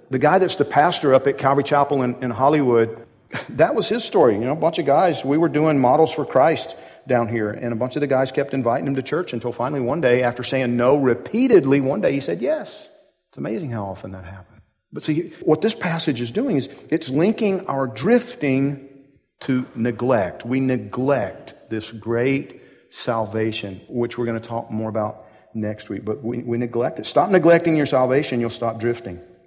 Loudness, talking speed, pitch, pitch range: -20 LUFS, 205 wpm, 130 Hz, 115-145 Hz